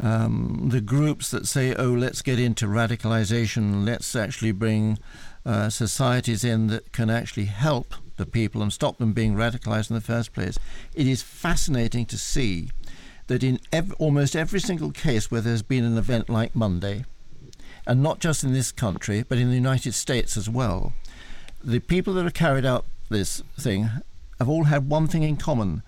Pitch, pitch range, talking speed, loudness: 120 Hz, 110-135 Hz, 180 wpm, -24 LUFS